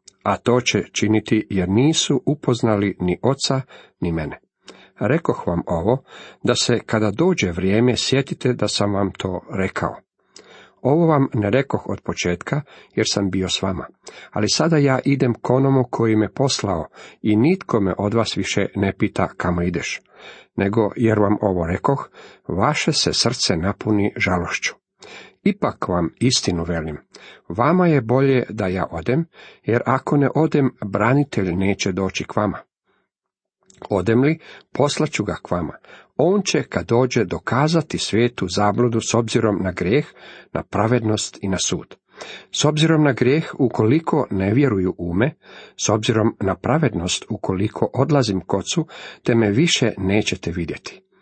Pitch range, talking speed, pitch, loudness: 95-135 Hz, 150 wpm, 110 Hz, -20 LUFS